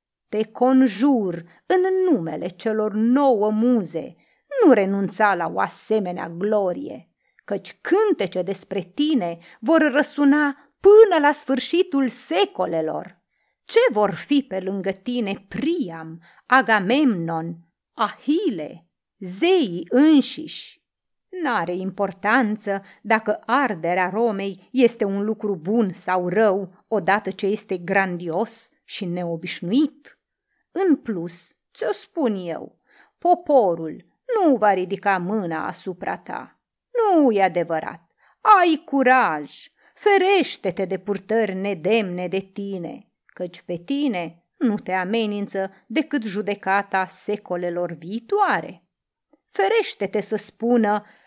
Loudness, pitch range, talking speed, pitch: -21 LUFS, 190-275 Hz, 100 wpm, 210 Hz